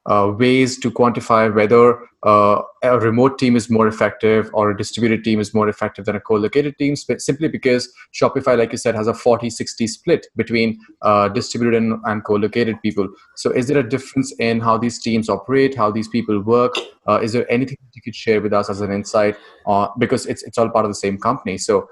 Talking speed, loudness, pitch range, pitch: 215 wpm, -18 LUFS, 105-125 Hz, 115 Hz